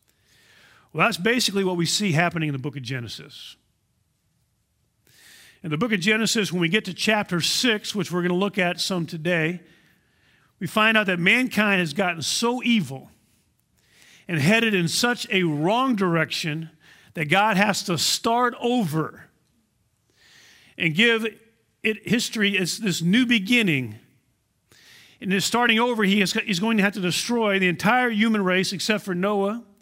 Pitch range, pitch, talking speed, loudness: 165-220 Hz, 195 Hz, 160 wpm, -22 LUFS